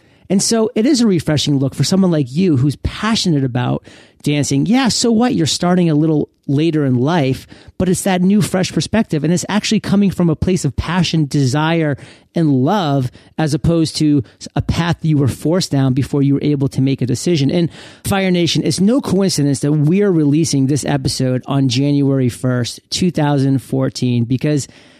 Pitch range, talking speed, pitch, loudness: 135-180 Hz, 180 wpm, 150 Hz, -15 LUFS